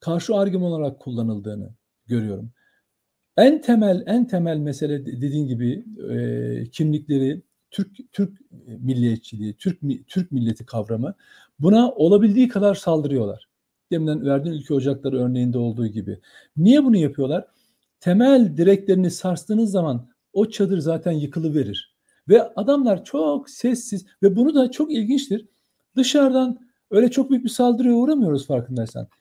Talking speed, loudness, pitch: 125 wpm, -21 LUFS, 170 Hz